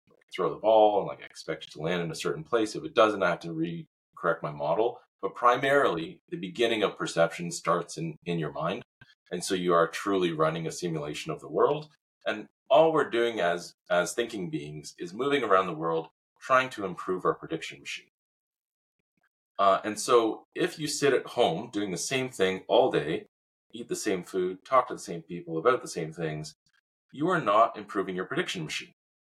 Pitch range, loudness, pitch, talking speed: 85-120 Hz, -28 LUFS, 95 Hz, 200 wpm